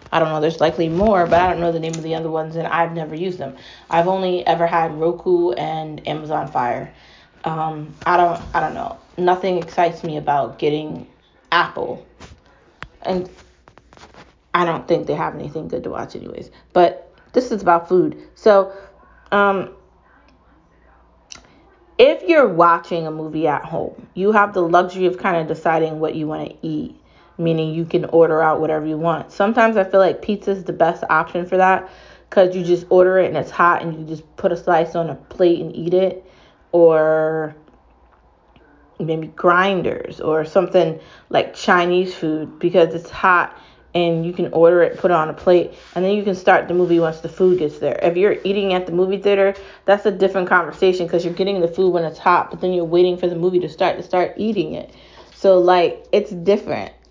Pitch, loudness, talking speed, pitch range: 175 Hz, -18 LUFS, 195 wpm, 160-185 Hz